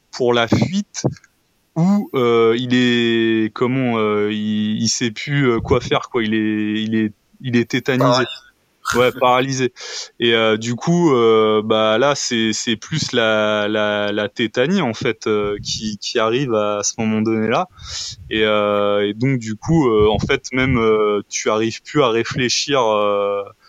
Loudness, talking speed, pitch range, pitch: -18 LUFS, 170 wpm, 105-125 Hz, 110 Hz